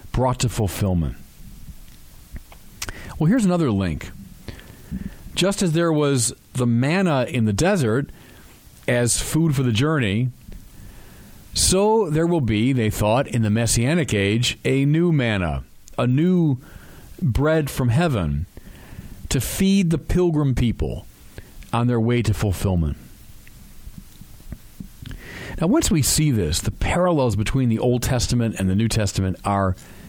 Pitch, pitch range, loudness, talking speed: 120 Hz, 105-155 Hz, -20 LUFS, 130 wpm